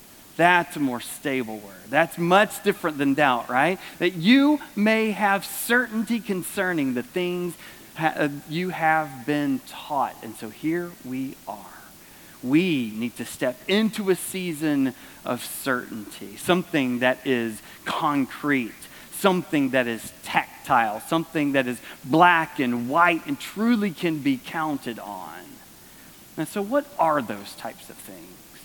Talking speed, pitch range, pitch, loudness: 140 wpm, 135-190 Hz, 160 Hz, -24 LUFS